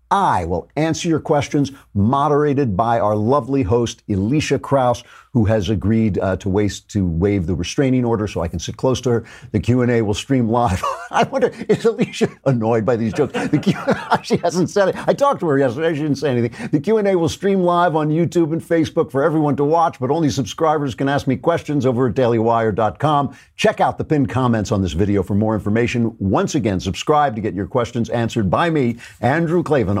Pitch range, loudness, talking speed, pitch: 110-155 Hz, -18 LUFS, 210 wpm, 130 Hz